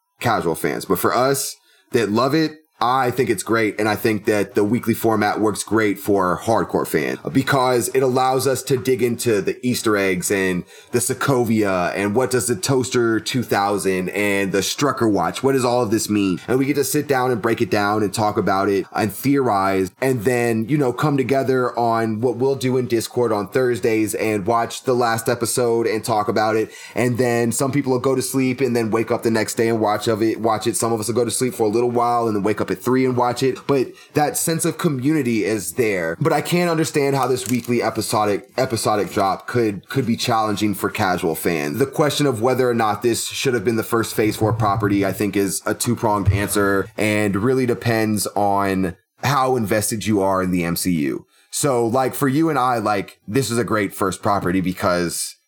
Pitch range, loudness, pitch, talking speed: 105-130 Hz, -19 LUFS, 115 Hz, 220 wpm